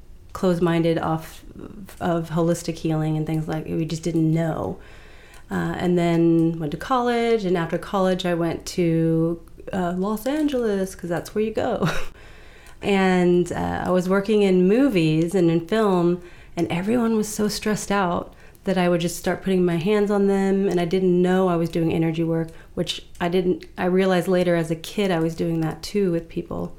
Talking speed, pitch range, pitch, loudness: 190 wpm, 165-190 Hz, 175 Hz, -22 LUFS